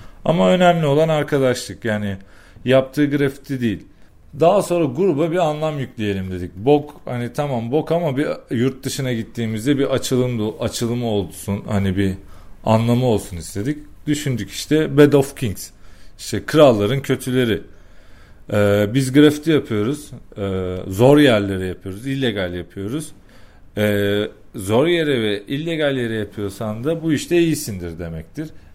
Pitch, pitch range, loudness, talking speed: 120 Hz, 100-145 Hz, -19 LUFS, 130 wpm